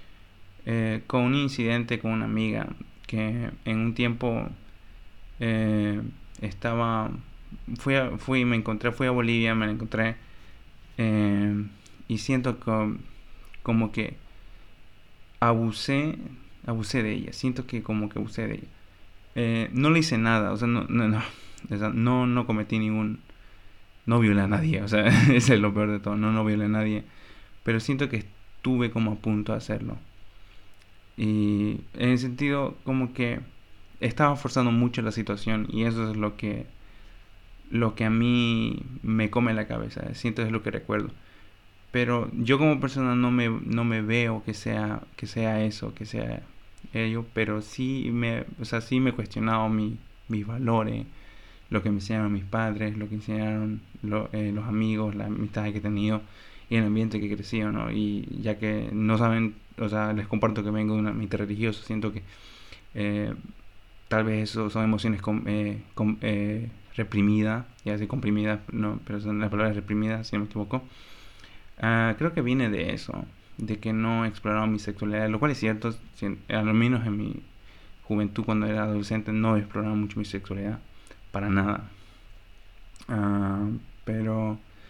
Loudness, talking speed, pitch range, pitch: -27 LUFS, 170 wpm, 105-115 Hz, 110 Hz